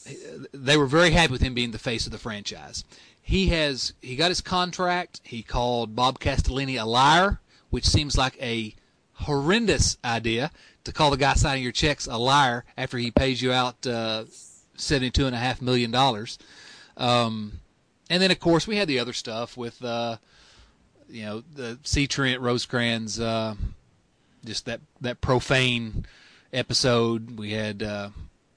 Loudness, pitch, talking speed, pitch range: -24 LUFS, 125 Hz, 165 wpm, 115-135 Hz